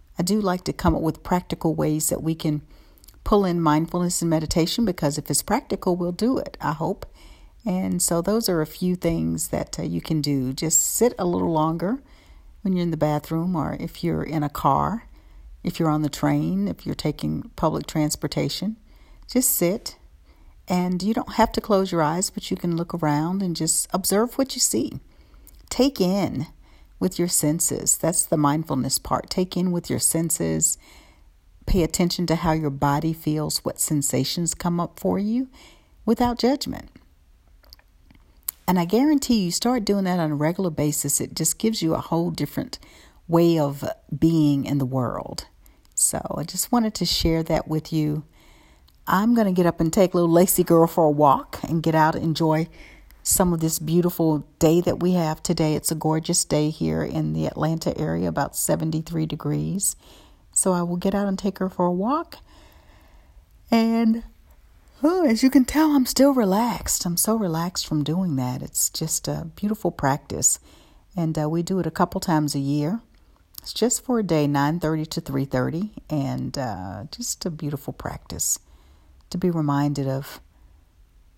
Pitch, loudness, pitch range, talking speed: 165 Hz, -23 LUFS, 145-185 Hz, 180 wpm